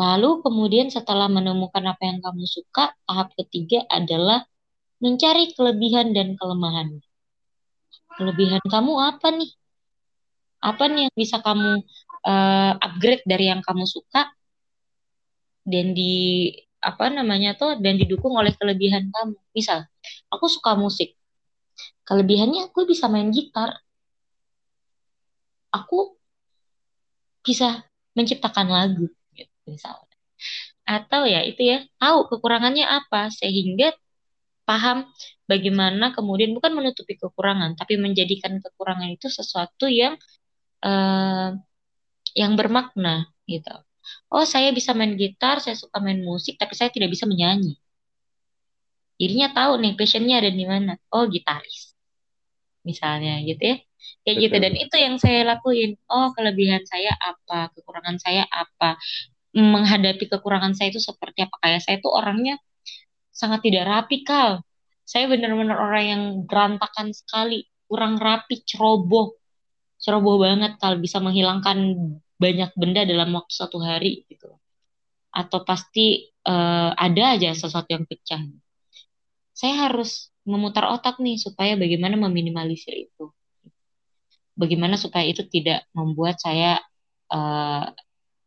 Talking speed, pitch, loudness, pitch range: 120 wpm, 200 Hz, -21 LUFS, 180-235 Hz